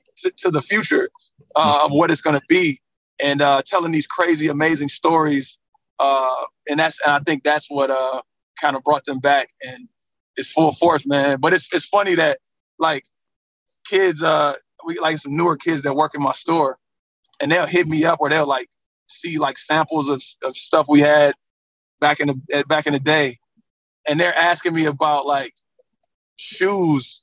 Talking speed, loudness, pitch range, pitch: 185 wpm, -19 LUFS, 140-170 Hz, 150 Hz